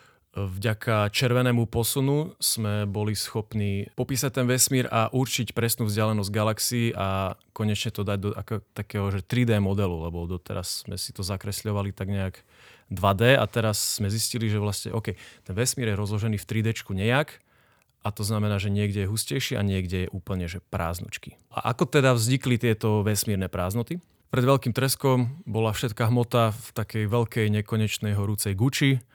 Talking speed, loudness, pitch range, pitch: 160 wpm, -26 LUFS, 100-120 Hz, 110 Hz